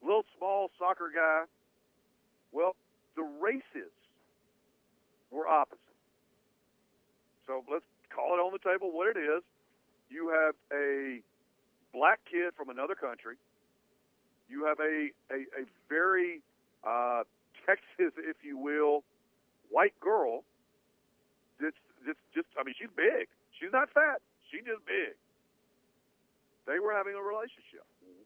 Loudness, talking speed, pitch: -32 LUFS, 125 wpm, 210 Hz